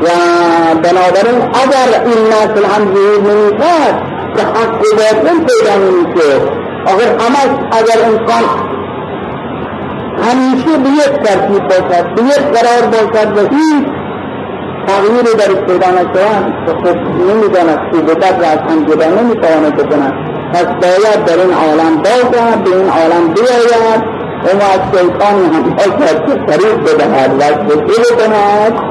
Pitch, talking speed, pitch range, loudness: 210 Hz, 85 wpm, 180-235 Hz, -9 LUFS